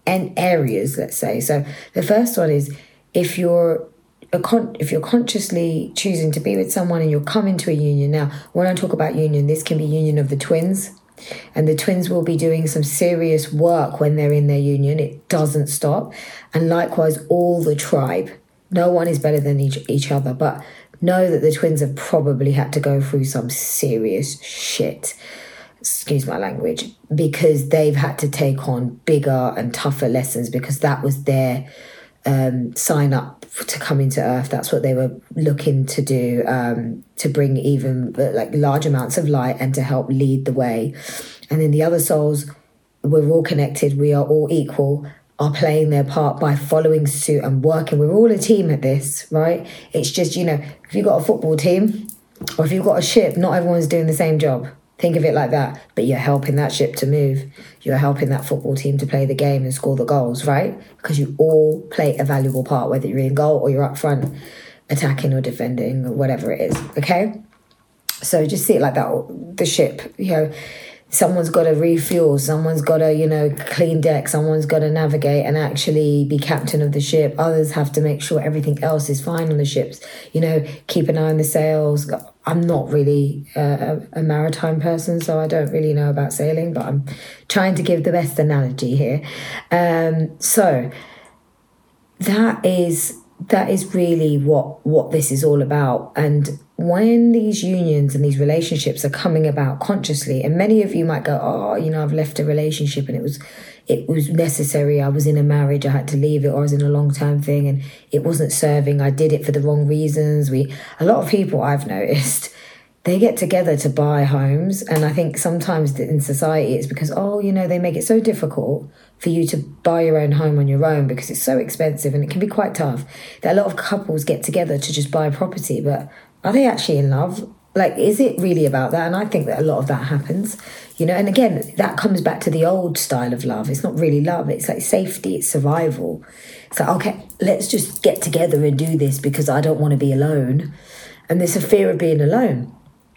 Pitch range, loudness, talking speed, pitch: 140-165 Hz, -18 LUFS, 210 wpm, 150 Hz